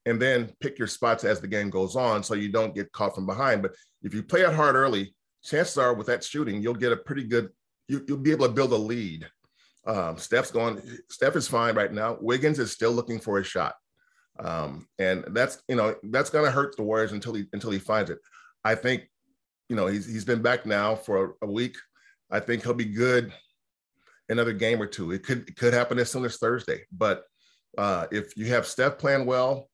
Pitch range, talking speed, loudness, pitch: 105-125 Hz, 225 wpm, -26 LUFS, 115 Hz